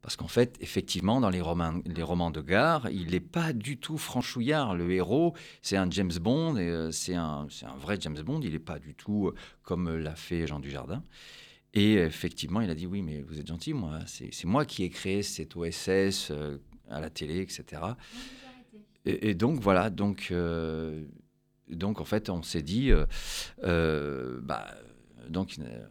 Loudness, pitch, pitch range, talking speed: -31 LUFS, 90 Hz, 80-105 Hz, 190 wpm